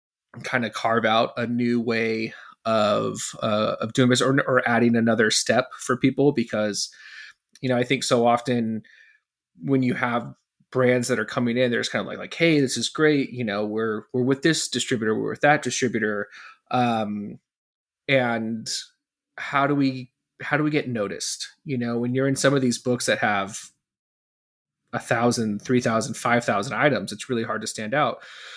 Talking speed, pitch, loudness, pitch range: 185 wpm, 120 Hz, -23 LUFS, 115-130 Hz